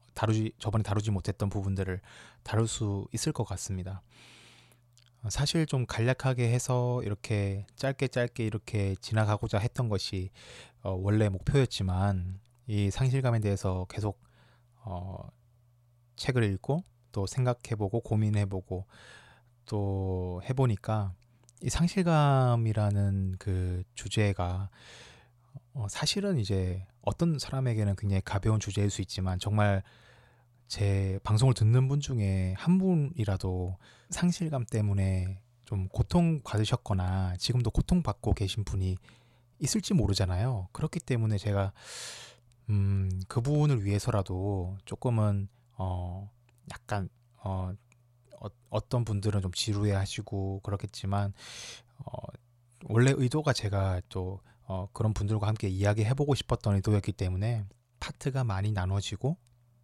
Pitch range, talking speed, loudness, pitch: 100-125 Hz, 265 characters per minute, -30 LUFS, 110 Hz